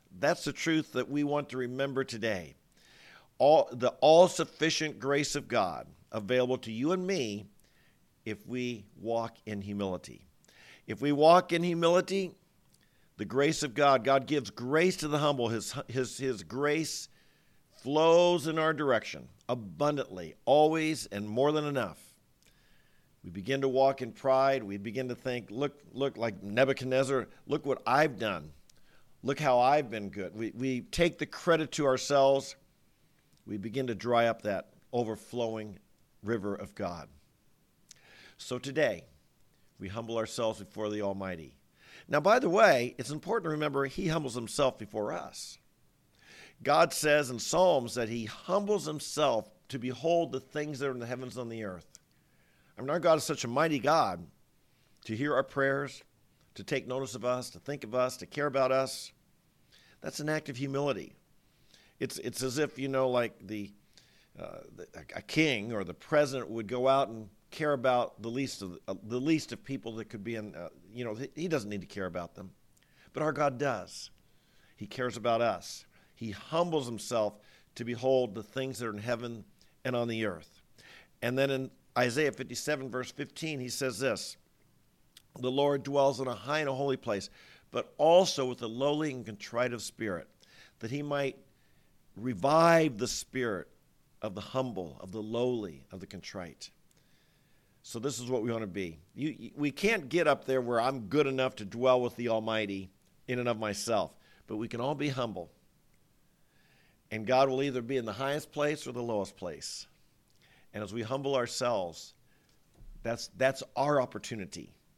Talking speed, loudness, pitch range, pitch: 175 wpm, -31 LUFS, 115-145 Hz, 130 Hz